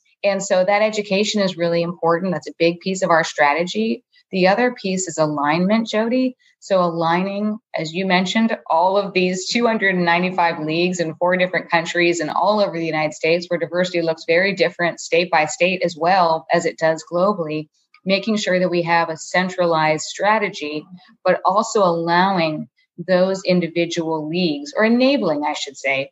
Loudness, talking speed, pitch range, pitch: -19 LUFS, 170 wpm, 165-195 Hz, 175 Hz